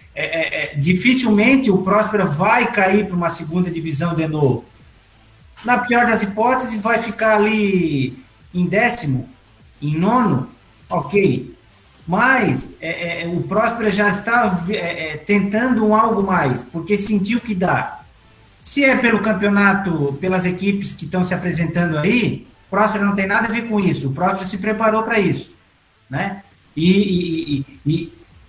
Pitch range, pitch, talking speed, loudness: 165-215 Hz, 195 Hz, 155 wpm, -18 LUFS